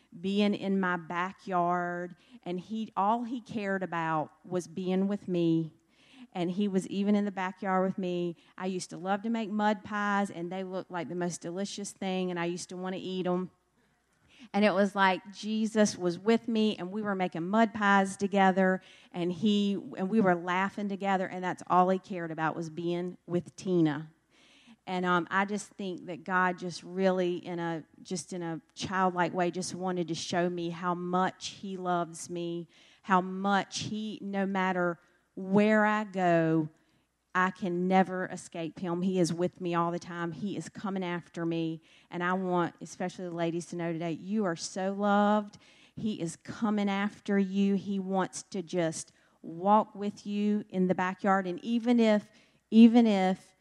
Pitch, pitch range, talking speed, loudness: 185 Hz, 175-200 Hz, 180 wpm, -30 LUFS